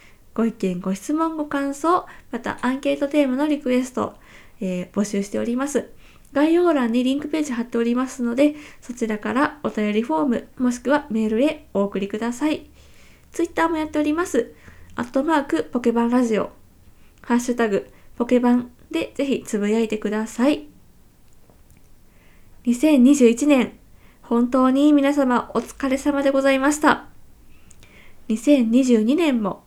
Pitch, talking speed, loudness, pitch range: 250 Hz, 300 characters per minute, -21 LUFS, 230-290 Hz